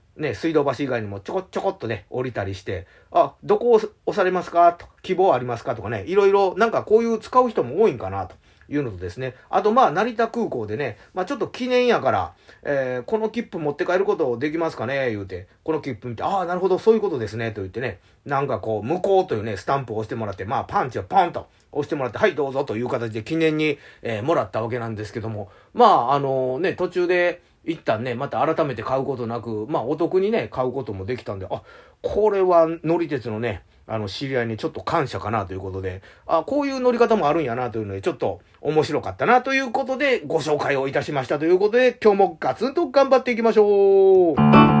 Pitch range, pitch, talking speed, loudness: 120-195 Hz, 155 Hz, 465 characters per minute, -22 LUFS